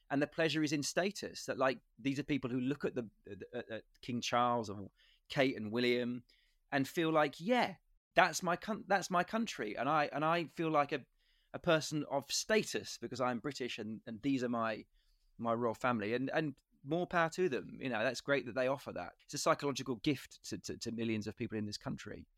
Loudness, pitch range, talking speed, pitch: -36 LUFS, 120-160 Hz, 215 wpm, 140 Hz